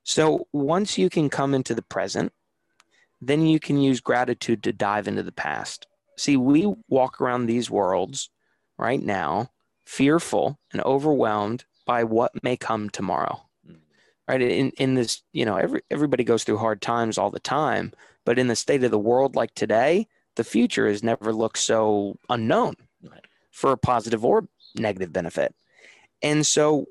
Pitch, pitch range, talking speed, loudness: 125 Hz, 115-150 Hz, 165 wpm, -23 LUFS